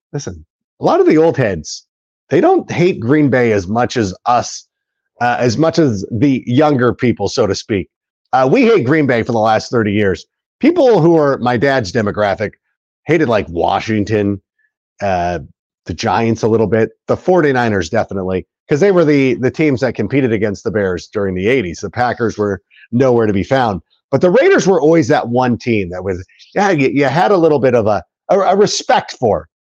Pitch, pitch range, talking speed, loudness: 120 Hz, 105-140 Hz, 200 wpm, -14 LUFS